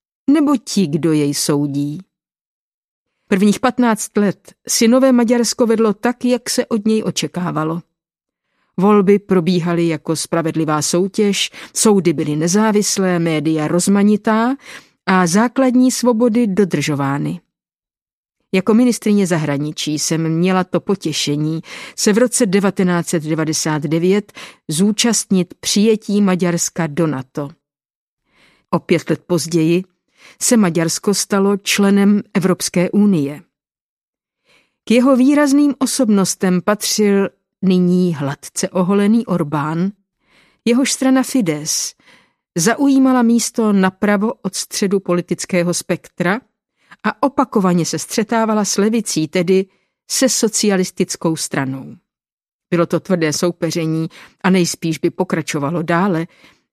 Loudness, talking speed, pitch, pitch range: -16 LUFS, 100 wpm, 190 Hz, 165-220 Hz